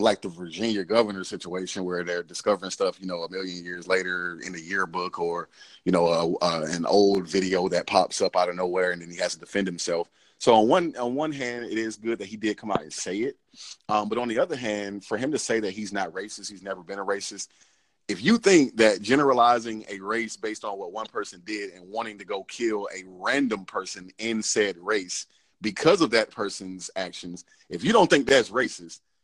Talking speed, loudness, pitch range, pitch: 225 wpm, -26 LUFS, 90-110 Hz, 100 Hz